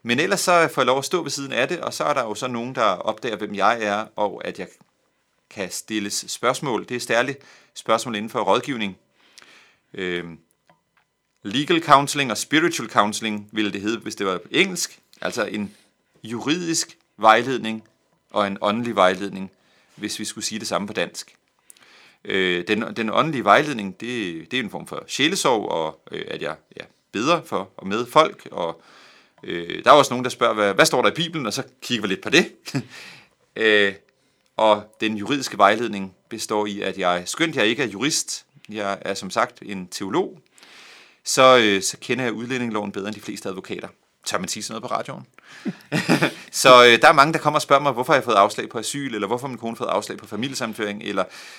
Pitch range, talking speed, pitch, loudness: 100-130 Hz, 200 wpm, 110 Hz, -21 LUFS